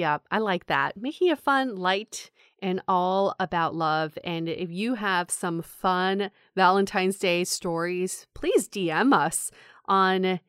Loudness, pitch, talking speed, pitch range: -25 LUFS, 185 Hz, 145 wpm, 175-200 Hz